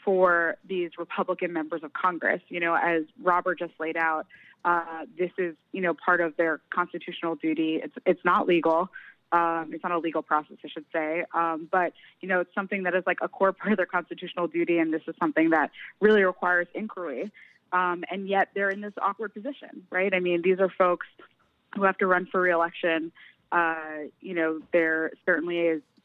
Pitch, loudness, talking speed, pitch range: 175 Hz, -26 LUFS, 200 wpm, 165-185 Hz